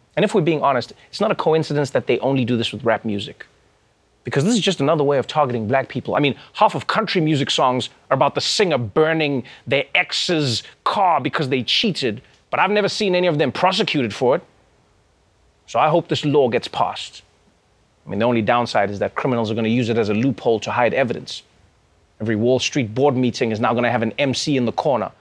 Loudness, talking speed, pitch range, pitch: -19 LUFS, 230 wpm, 115-155 Hz, 130 Hz